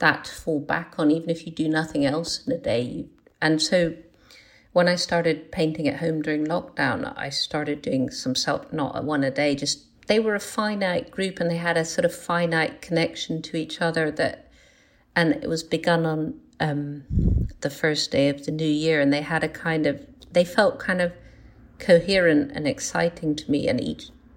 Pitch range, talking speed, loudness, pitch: 150-175 Hz, 200 wpm, -24 LUFS, 160 Hz